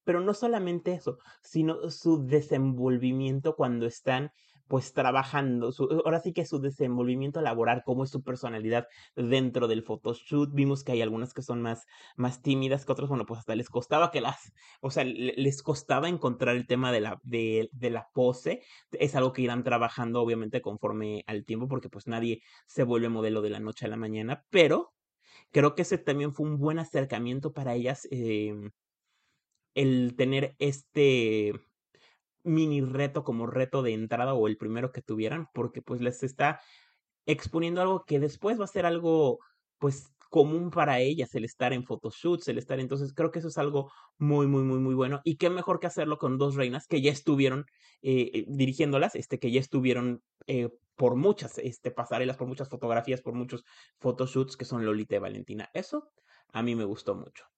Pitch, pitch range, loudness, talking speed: 130 Hz, 120-145 Hz, -29 LUFS, 180 wpm